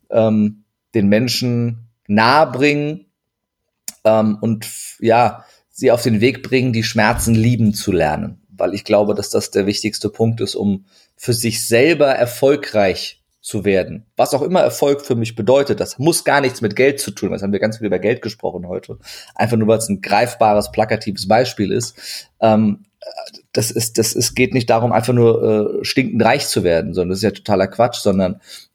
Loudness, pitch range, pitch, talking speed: -16 LUFS, 105-120 Hz, 110 Hz, 190 wpm